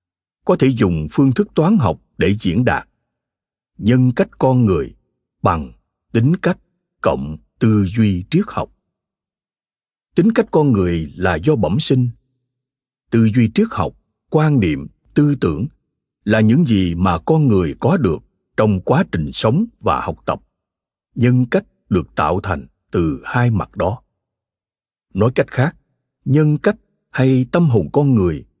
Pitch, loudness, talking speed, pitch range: 120 Hz, -17 LUFS, 150 wpm, 95-145 Hz